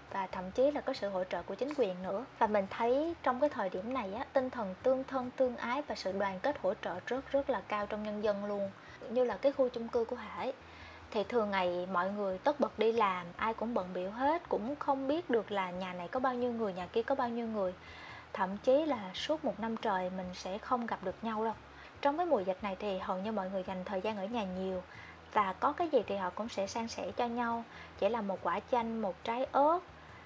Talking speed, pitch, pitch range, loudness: 260 wpm, 220 Hz, 190-260 Hz, -35 LUFS